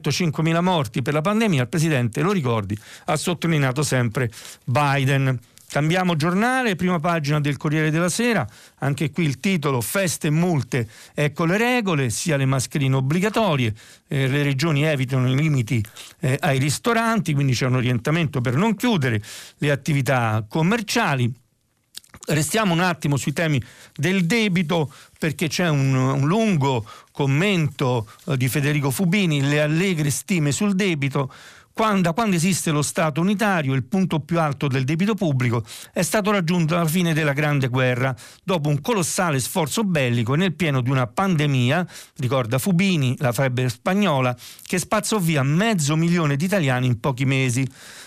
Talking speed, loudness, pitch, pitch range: 150 wpm, -21 LUFS, 150 Hz, 130-180 Hz